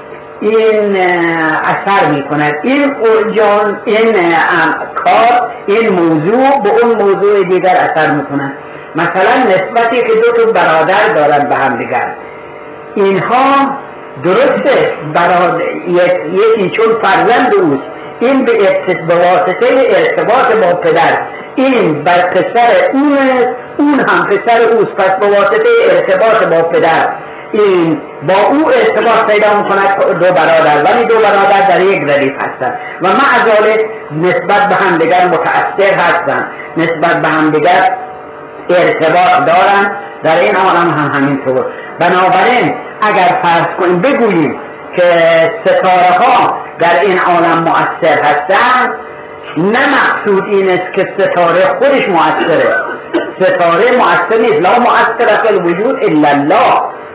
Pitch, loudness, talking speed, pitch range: 195 Hz, -9 LUFS, 120 wpm, 175-235 Hz